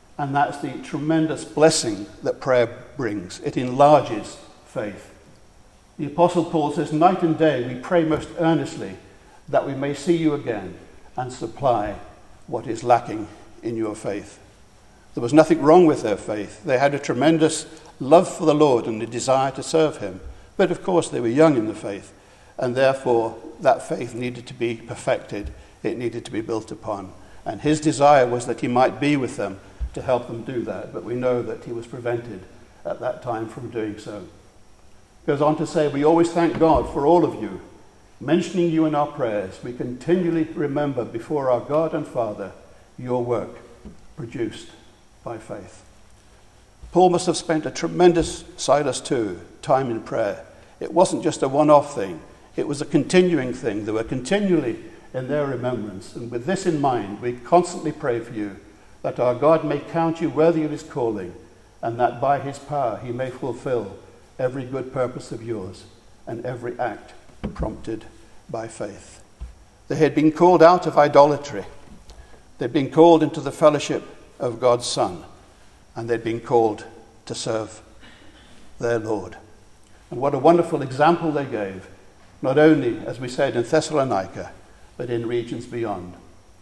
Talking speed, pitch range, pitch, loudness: 170 wpm, 110-155 Hz, 130 Hz, -21 LUFS